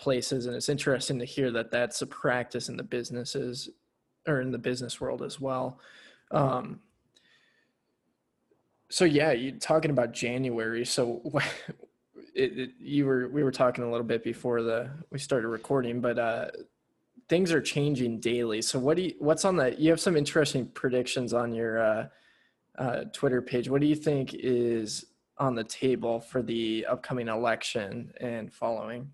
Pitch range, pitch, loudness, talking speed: 120-145 Hz, 125 Hz, -29 LUFS, 165 wpm